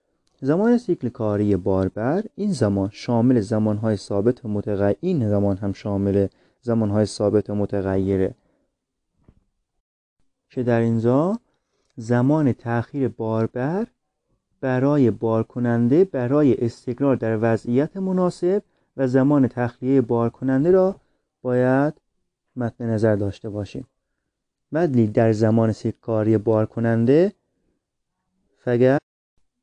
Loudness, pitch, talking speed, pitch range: -21 LUFS, 120 Hz, 105 wpm, 105-135 Hz